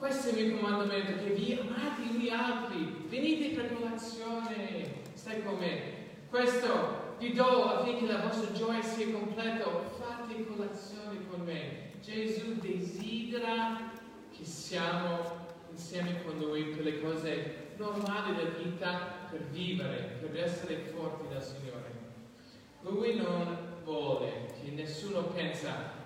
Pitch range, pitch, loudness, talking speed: 165-225 Hz, 195 Hz, -35 LUFS, 125 wpm